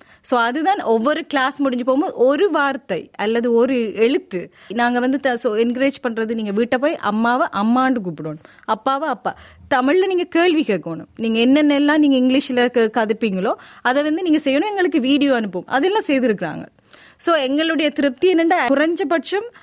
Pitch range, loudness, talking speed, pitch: 230-305 Hz, -18 LUFS, 110 wpm, 265 Hz